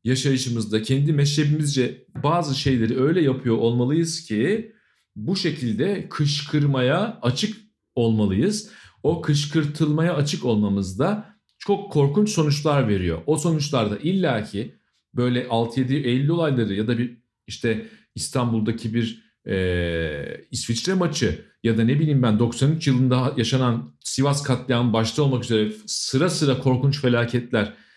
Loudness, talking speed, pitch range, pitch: -22 LUFS, 120 wpm, 115-155 Hz, 130 Hz